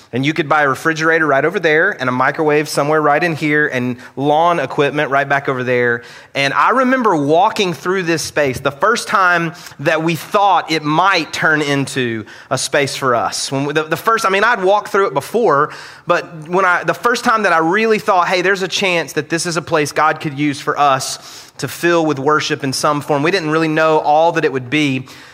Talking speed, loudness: 225 wpm, -15 LUFS